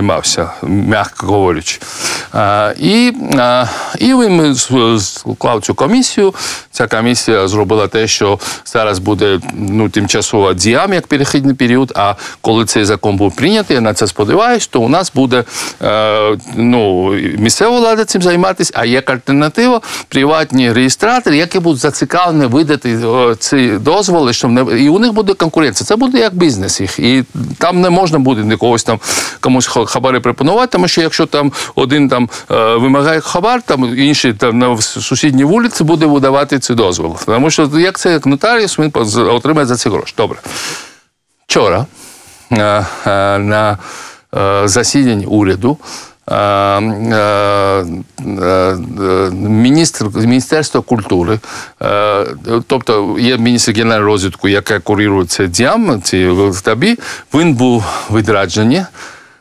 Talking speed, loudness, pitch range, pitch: 125 wpm, -11 LUFS, 105-155 Hz, 125 Hz